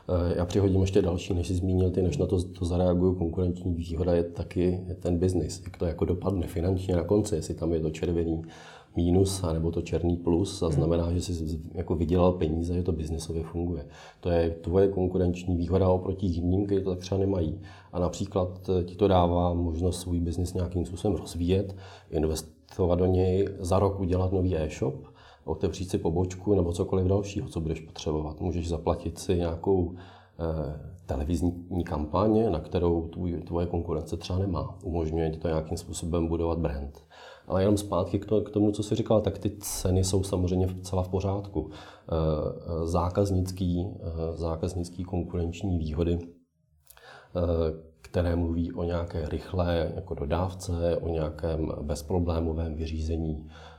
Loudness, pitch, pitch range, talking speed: -28 LUFS, 90 Hz, 85-95 Hz, 160 wpm